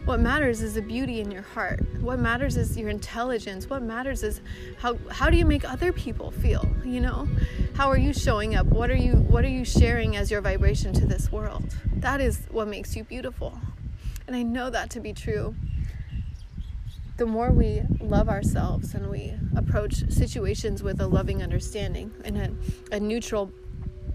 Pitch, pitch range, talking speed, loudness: 225 Hz, 210-245 Hz, 185 wpm, -27 LUFS